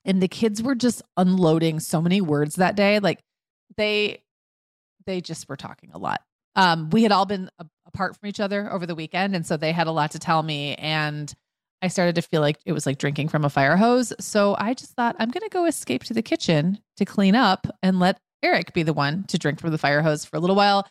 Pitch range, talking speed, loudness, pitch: 160-205 Hz, 245 wpm, -22 LUFS, 180 Hz